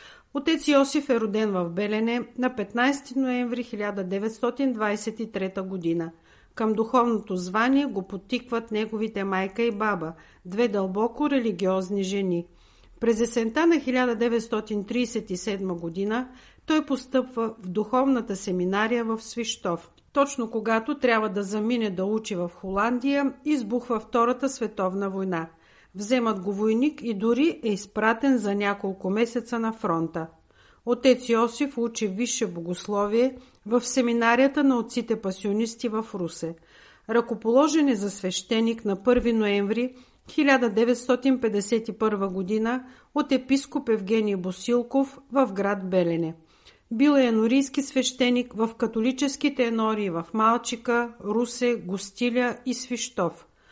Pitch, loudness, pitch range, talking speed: 225 Hz, -25 LUFS, 200-250 Hz, 115 wpm